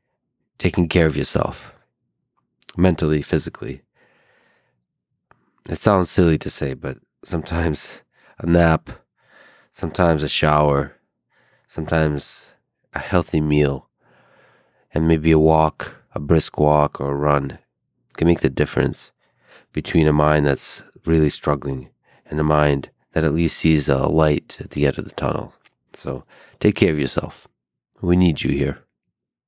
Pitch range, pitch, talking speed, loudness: 75-80 Hz, 75 Hz, 135 wpm, -20 LUFS